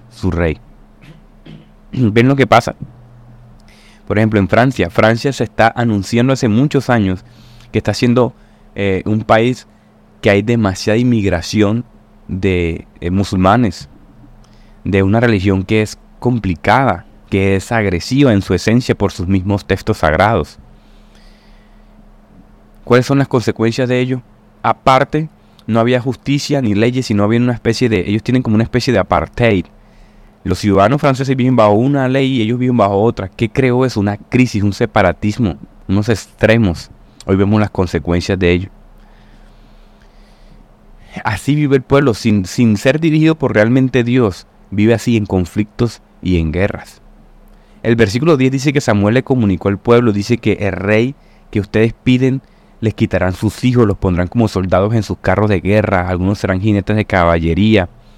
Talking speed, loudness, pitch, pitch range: 155 wpm, -14 LUFS, 110 Hz, 100-120 Hz